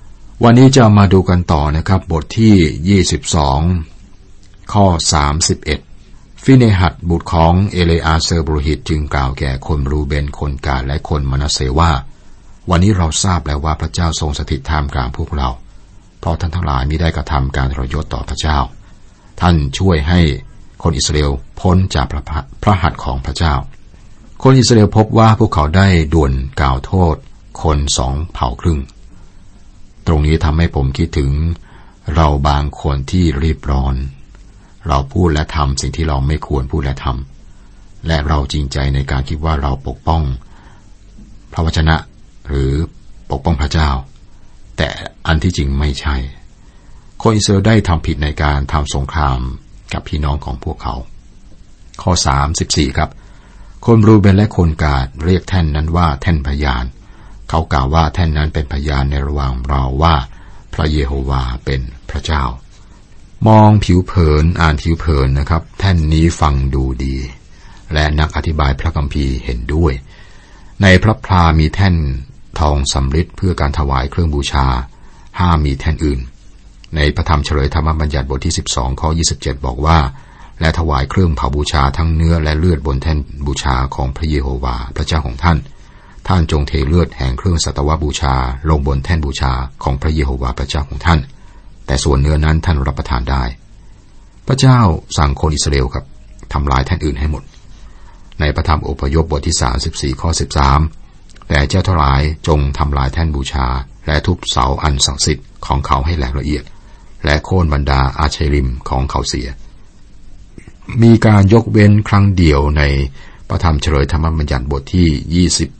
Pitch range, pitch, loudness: 70-90 Hz, 80 Hz, -15 LUFS